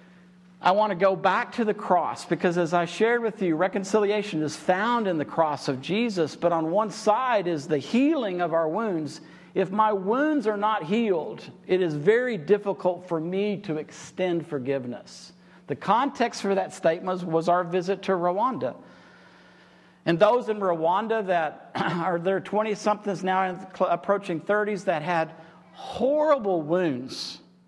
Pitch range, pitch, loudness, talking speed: 165-210 Hz, 185 Hz, -25 LUFS, 160 wpm